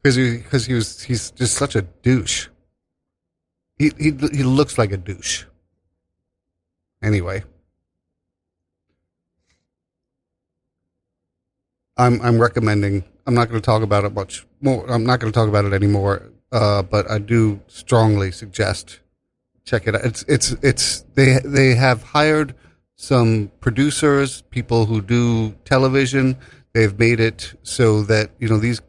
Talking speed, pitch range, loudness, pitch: 140 wpm, 95-125 Hz, -18 LUFS, 110 Hz